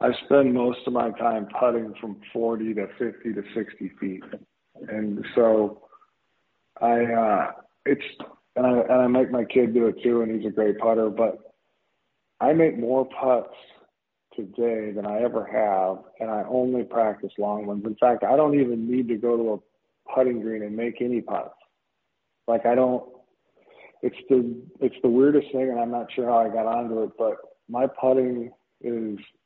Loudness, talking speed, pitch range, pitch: -24 LUFS, 180 wpm, 110-125 Hz, 115 Hz